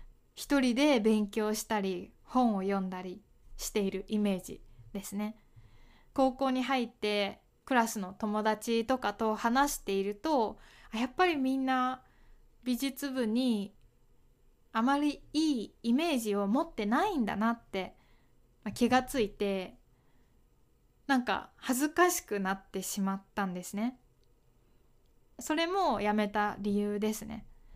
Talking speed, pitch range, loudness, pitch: 240 characters per minute, 200-260 Hz, -32 LUFS, 220 Hz